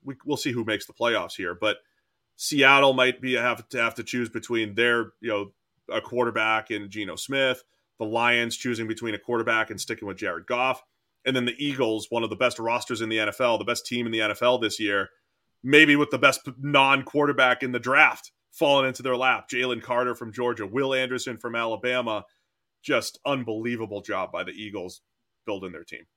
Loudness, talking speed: -24 LUFS, 195 wpm